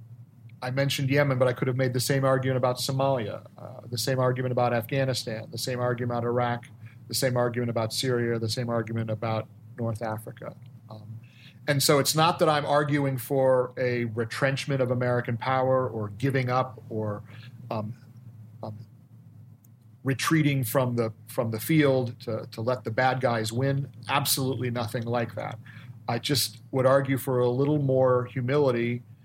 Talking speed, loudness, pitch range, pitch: 165 wpm, -26 LUFS, 115-135 Hz, 125 Hz